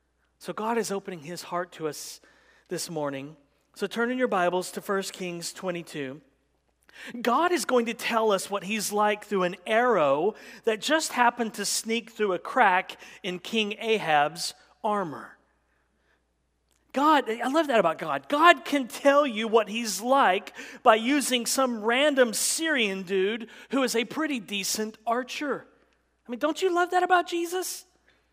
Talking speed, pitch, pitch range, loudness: 160 wpm, 225 Hz, 185-255 Hz, -26 LUFS